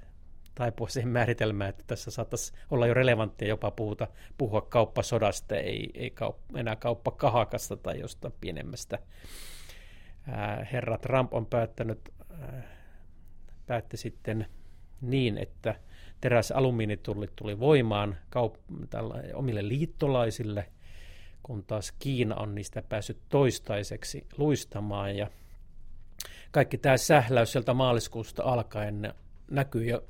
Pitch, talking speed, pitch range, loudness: 110 Hz, 110 wpm, 95-120 Hz, -30 LUFS